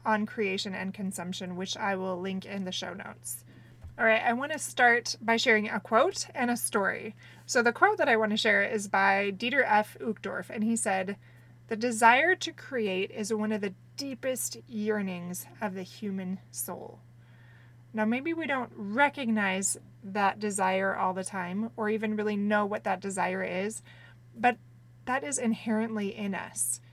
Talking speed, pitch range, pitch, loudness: 175 wpm, 185-225 Hz, 205 Hz, -29 LUFS